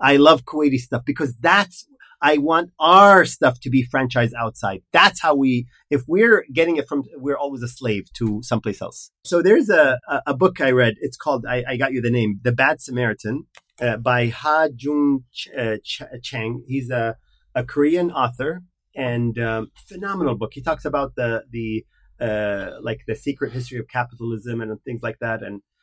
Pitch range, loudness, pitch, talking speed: 115-145 Hz, -20 LUFS, 125 Hz, 190 wpm